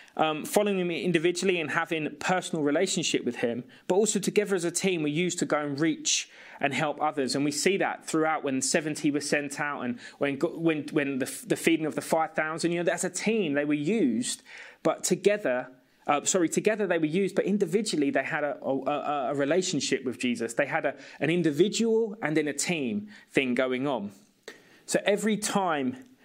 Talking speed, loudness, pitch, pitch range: 200 wpm, -27 LUFS, 165 Hz, 145-195 Hz